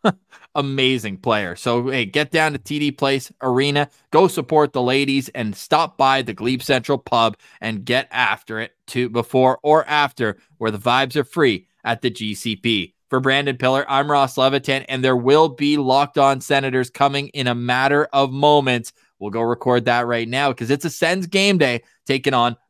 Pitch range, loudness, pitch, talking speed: 120-145 Hz, -19 LUFS, 135 Hz, 185 wpm